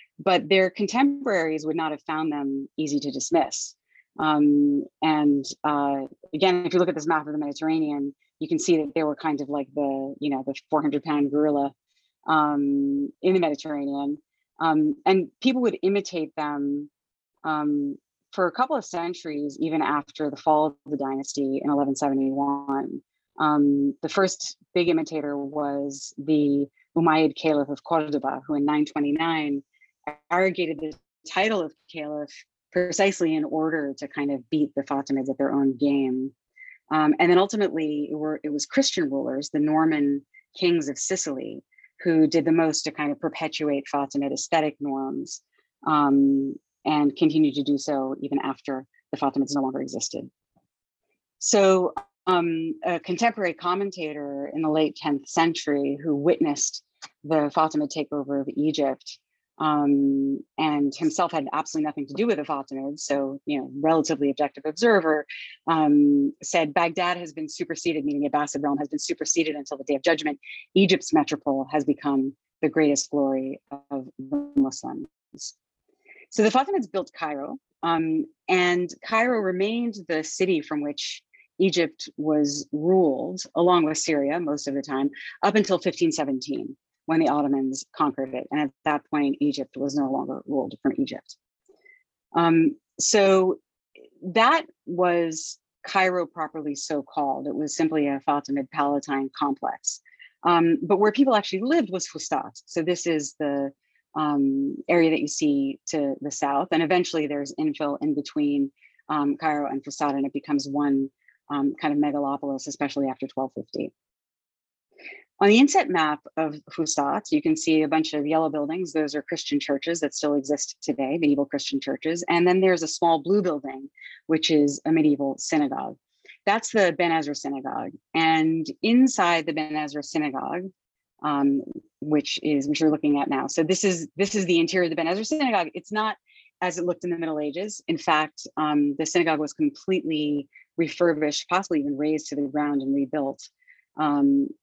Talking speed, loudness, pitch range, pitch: 160 wpm, -24 LUFS, 145-180 Hz, 155 Hz